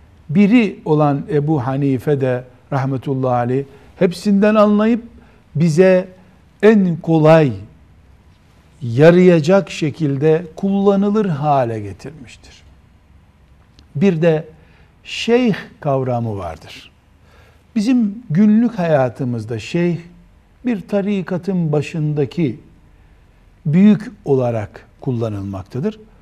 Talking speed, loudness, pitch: 75 wpm, -16 LUFS, 145 Hz